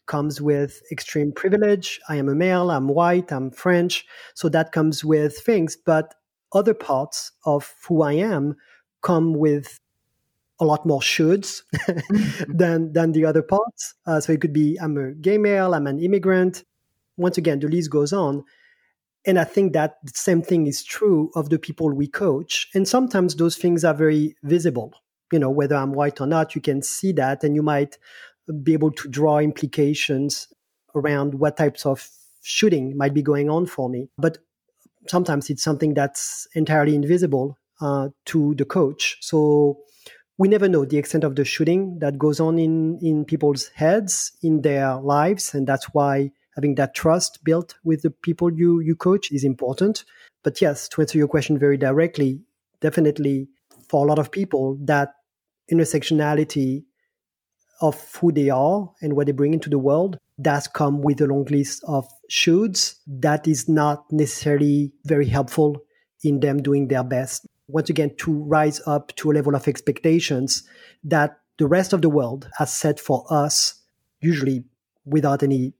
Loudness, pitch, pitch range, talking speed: -21 LUFS, 150 Hz, 145-165 Hz, 175 wpm